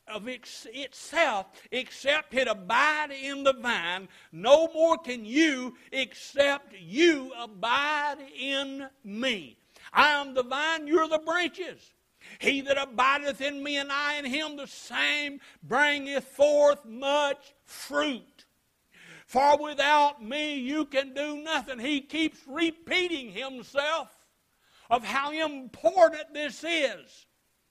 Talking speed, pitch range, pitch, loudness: 120 wpm, 265-300 Hz, 280 Hz, -27 LUFS